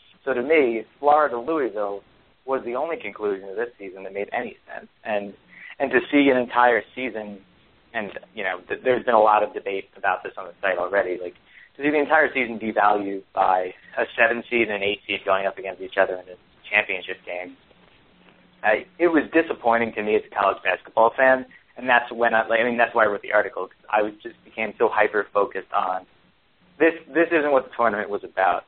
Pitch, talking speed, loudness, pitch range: 115 Hz, 215 wpm, -22 LUFS, 100-130 Hz